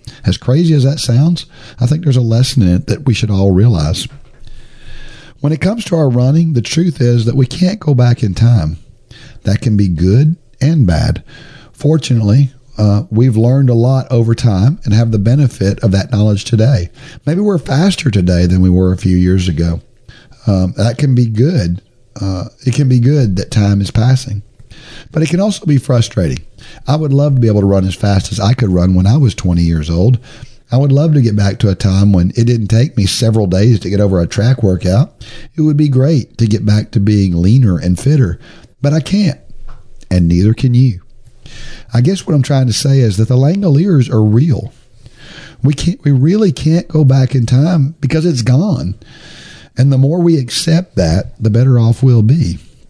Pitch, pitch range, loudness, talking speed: 120 Hz, 105-140 Hz, -12 LUFS, 210 wpm